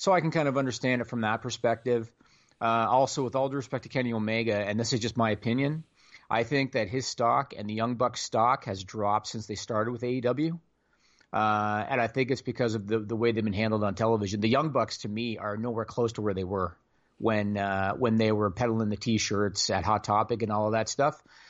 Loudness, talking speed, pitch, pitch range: -28 LUFS, 235 wpm, 115 Hz, 105-125 Hz